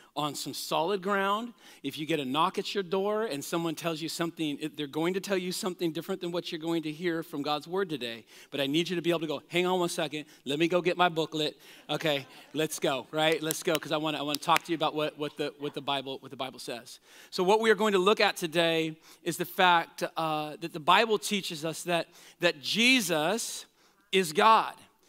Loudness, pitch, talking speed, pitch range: -29 LUFS, 165 Hz, 245 wpm, 150-185 Hz